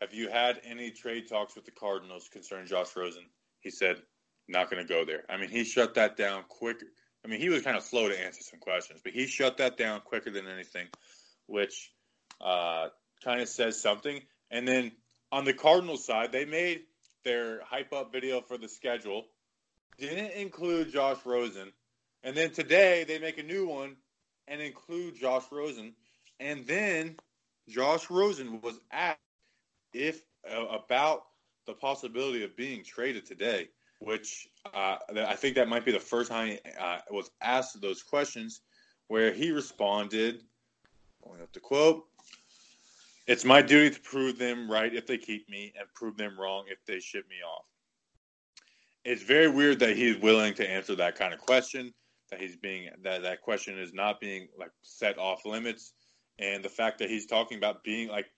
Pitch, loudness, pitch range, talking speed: 120 Hz, -30 LUFS, 105-140 Hz, 180 wpm